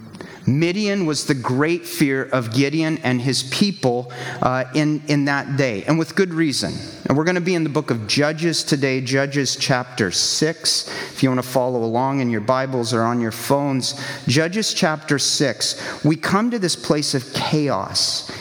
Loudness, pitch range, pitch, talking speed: -20 LUFS, 125-155 Hz, 140 Hz, 185 wpm